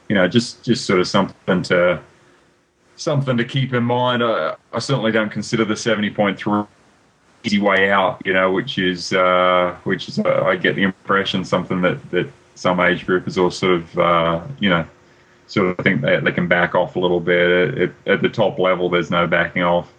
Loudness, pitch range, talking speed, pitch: -18 LUFS, 90-110 Hz, 205 wpm, 95 Hz